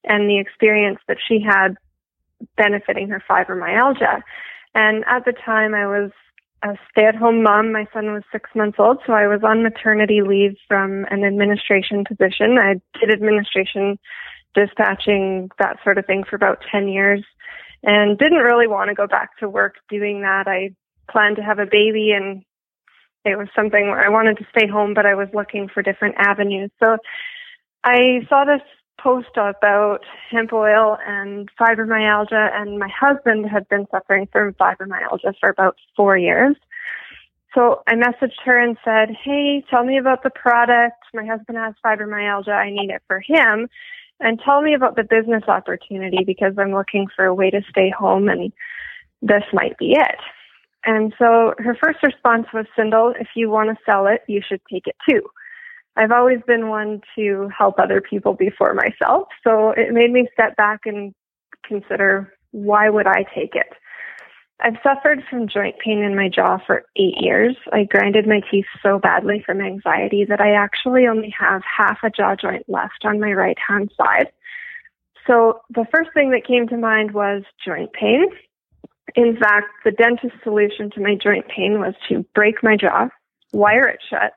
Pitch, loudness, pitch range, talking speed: 215 Hz, -17 LUFS, 200-235 Hz, 175 wpm